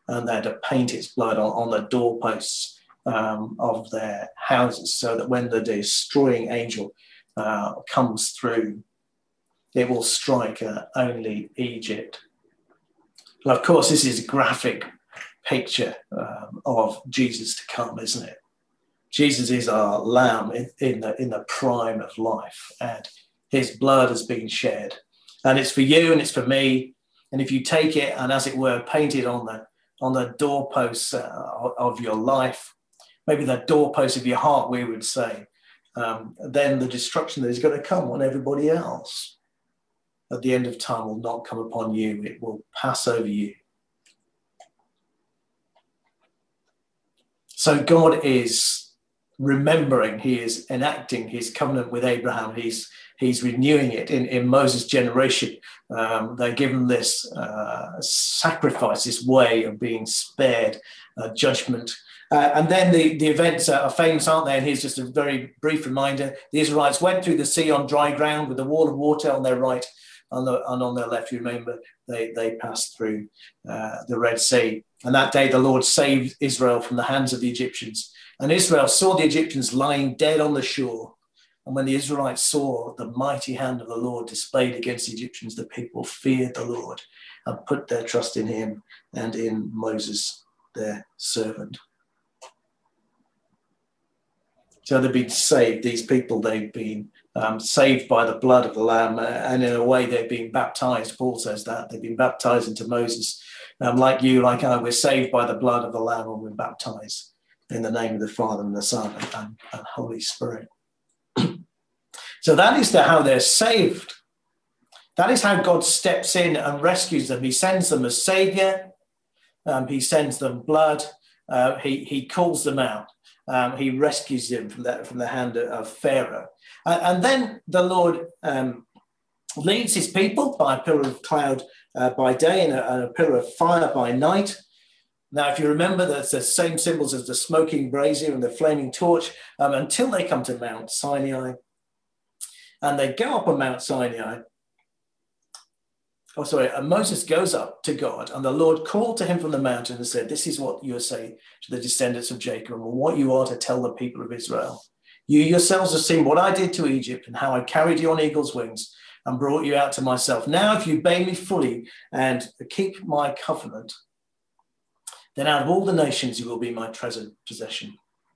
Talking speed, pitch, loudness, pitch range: 180 wpm, 130 Hz, -22 LUFS, 120-150 Hz